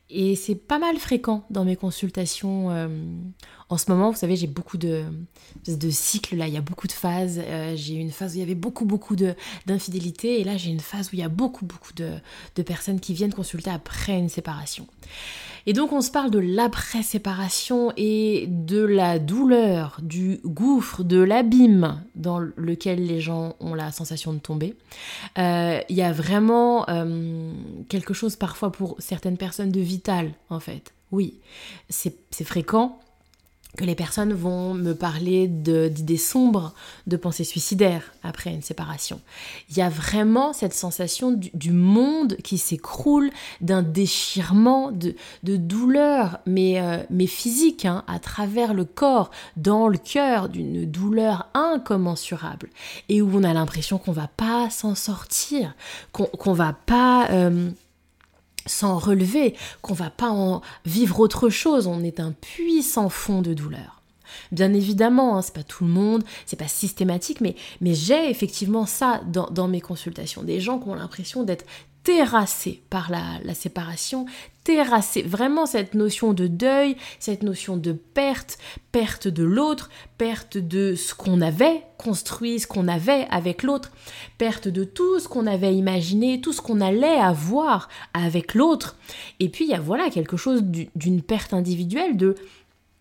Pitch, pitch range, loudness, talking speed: 190 Hz, 175-225 Hz, -23 LUFS, 170 wpm